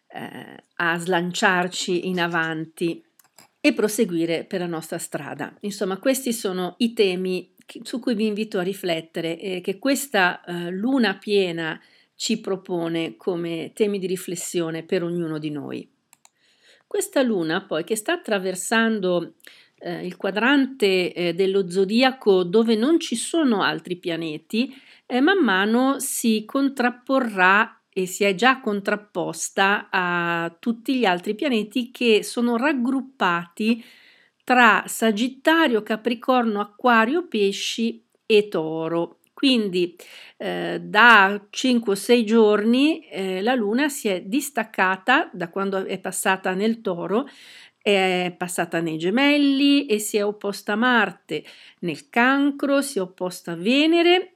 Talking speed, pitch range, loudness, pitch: 130 wpm, 180-245 Hz, -22 LUFS, 205 Hz